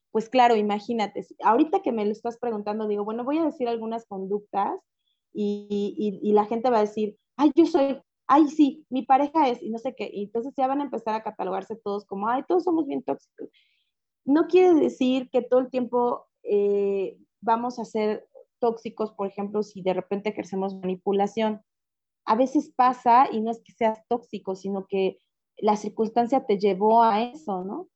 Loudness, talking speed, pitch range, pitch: -25 LUFS, 190 wpm, 210-265 Hz, 230 Hz